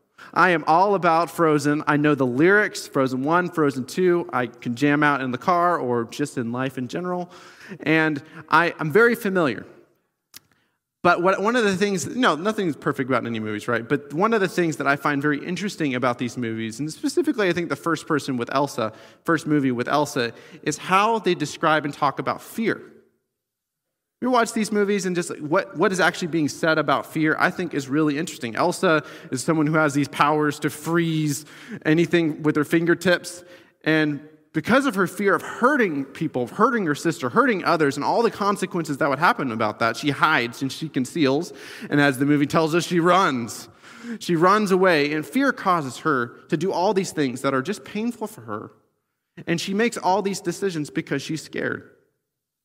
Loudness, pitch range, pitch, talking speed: -22 LUFS, 140-180 Hz, 155 Hz, 195 wpm